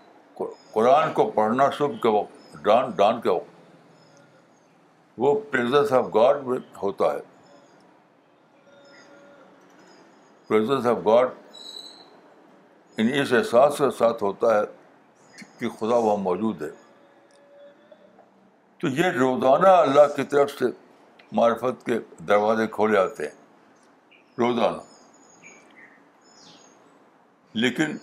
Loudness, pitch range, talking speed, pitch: -22 LUFS, 110-145 Hz, 100 wpm, 130 Hz